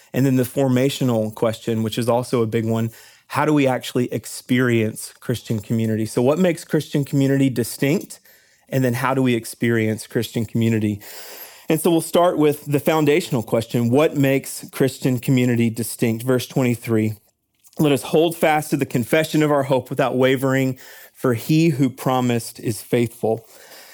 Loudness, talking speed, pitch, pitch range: -20 LUFS, 165 wpm, 130 Hz, 115-145 Hz